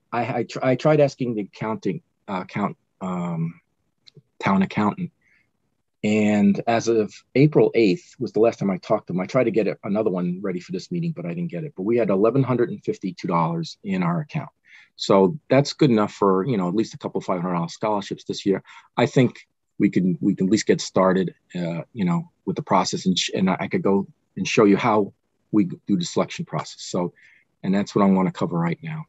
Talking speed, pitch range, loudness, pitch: 215 wpm, 95-155 Hz, -22 LUFS, 115 Hz